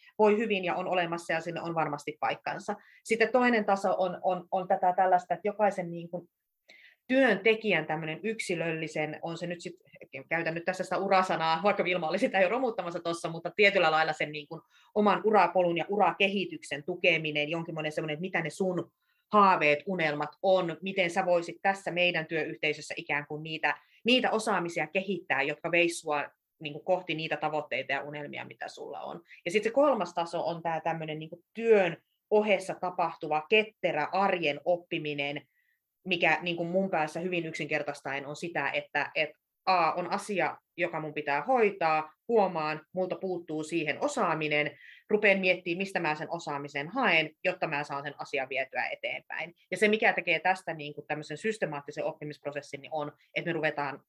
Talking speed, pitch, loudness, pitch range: 160 wpm, 170 Hz, -29 LUFS, 155-190 Hz